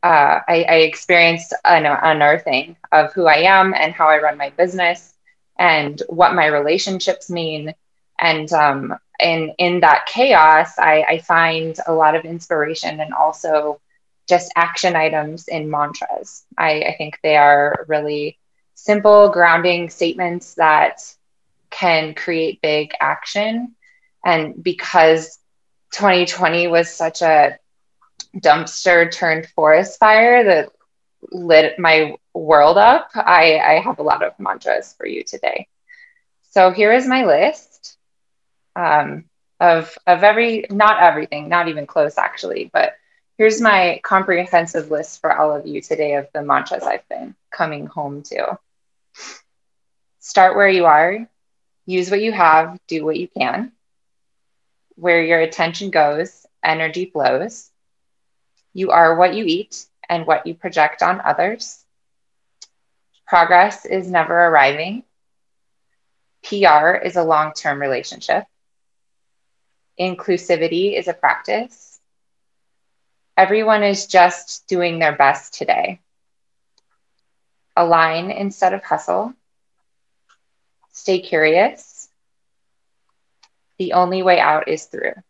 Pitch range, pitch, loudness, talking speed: 155-195 Hz, 170 Hz, -15 LUFS, 125 wpm